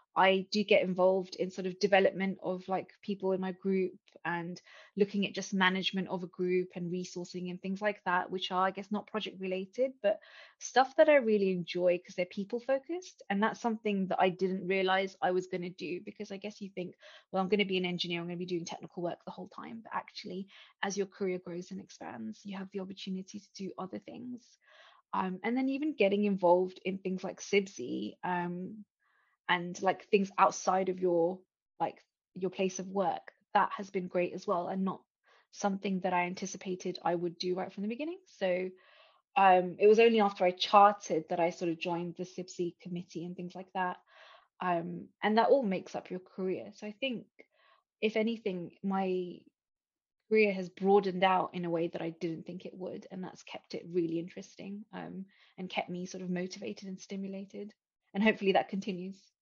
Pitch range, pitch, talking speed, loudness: 180-205 Hz, 190 Hz, 205 wpm, -32 LUFS